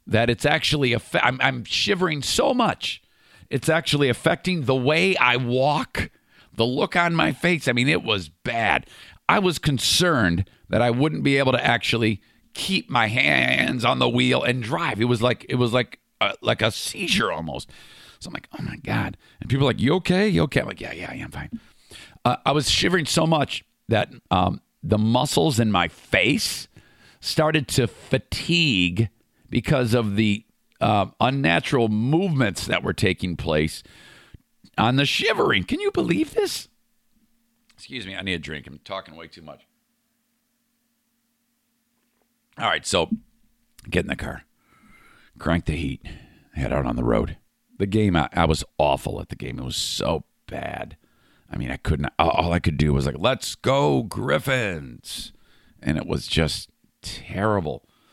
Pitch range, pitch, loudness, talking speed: 105-170 Hz, 125 Hz, -22 LUFS, 175 wpm